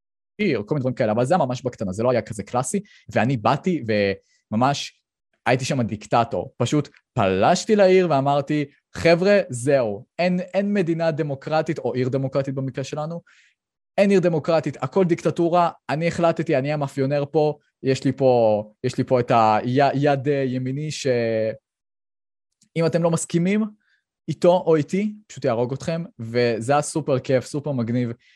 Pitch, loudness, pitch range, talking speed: 140 Hz, -22 LUFS, 125-165 Hz, 145 wpm